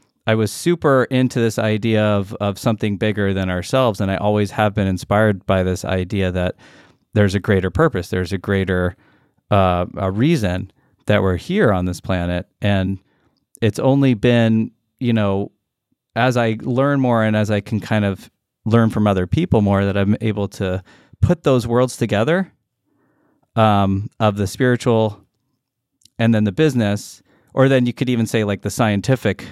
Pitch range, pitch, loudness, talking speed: 100-120 Hz, 105 Hz, -18 LUFS, 170 wpm